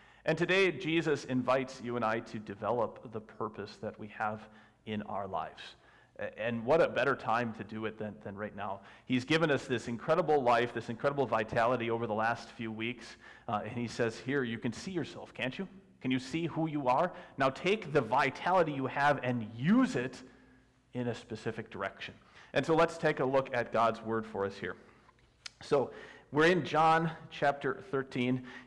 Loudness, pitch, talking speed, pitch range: -33 LUFS, 125 Hz, 190 wpm, 115-145 Hz